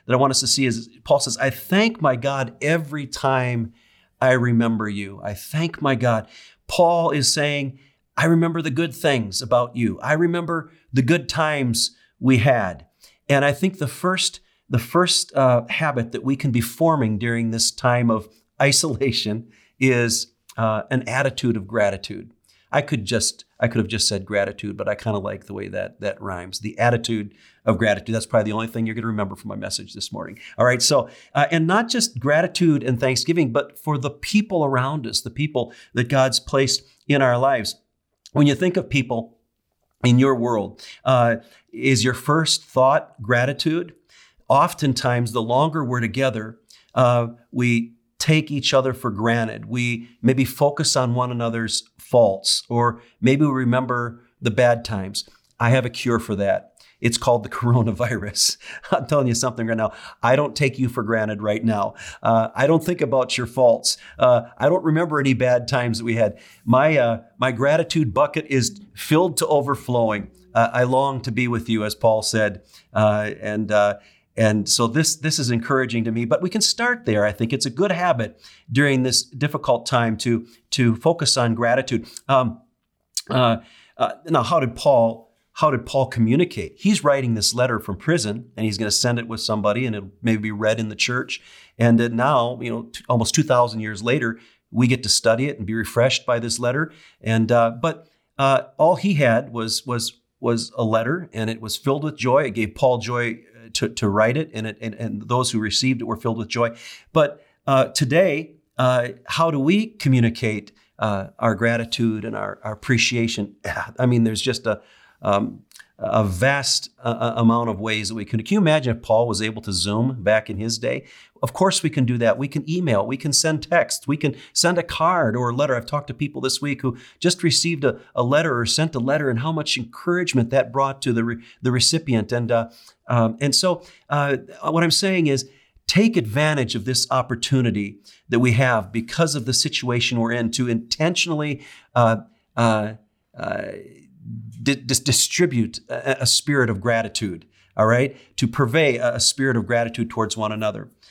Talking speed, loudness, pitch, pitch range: 195 wpm, -21 LUFS, 120 Hz, 115-140 Hz